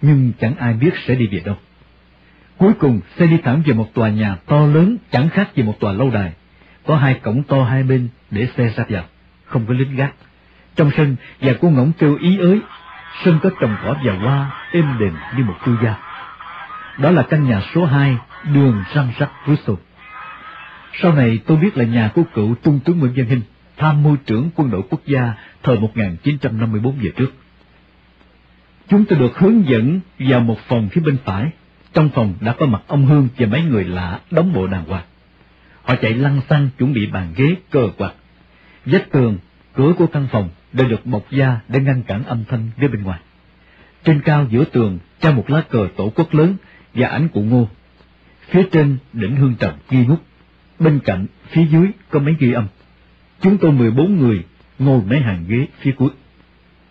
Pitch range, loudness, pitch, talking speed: 105-150 Hz, -16 LUFS, 130 Hz, 200 wpm